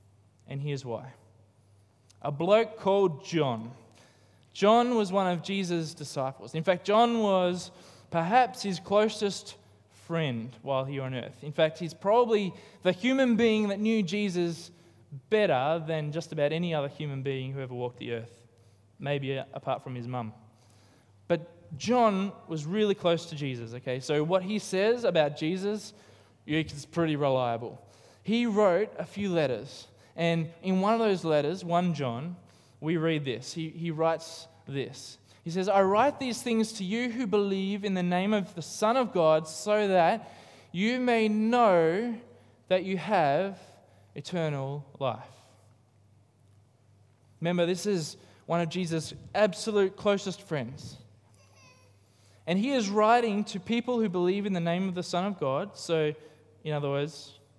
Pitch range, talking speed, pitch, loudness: 130-195 Hz, 155 wpm, 160 Hz, -29 LUFS